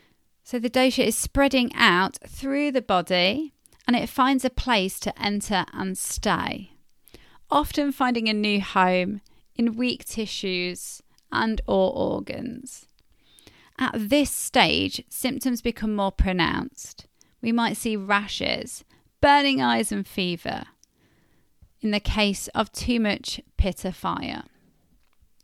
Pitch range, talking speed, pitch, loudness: 195-260 Hz, 125 wpm, 225 Hz, -24 LUFS